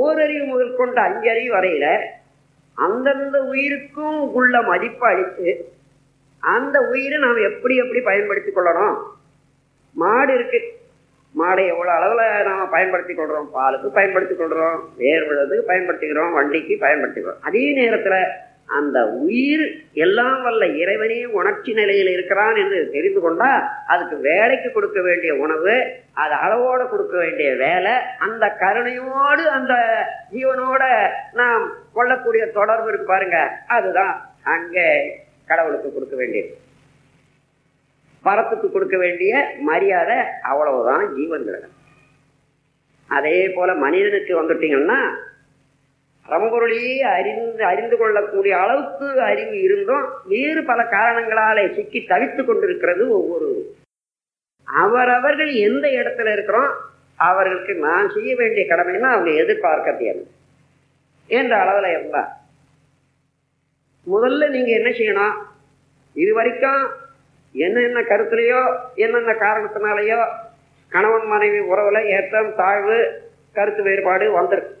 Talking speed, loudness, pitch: 105 wpm, -18 LUFS, 235 Hz